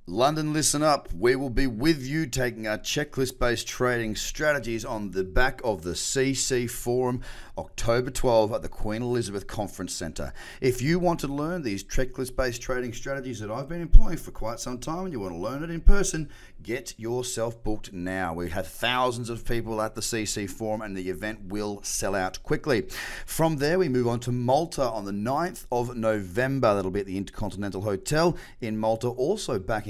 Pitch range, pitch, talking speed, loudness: 105-135 Hz, 120 Hz, 190 wpm, -28 LUFS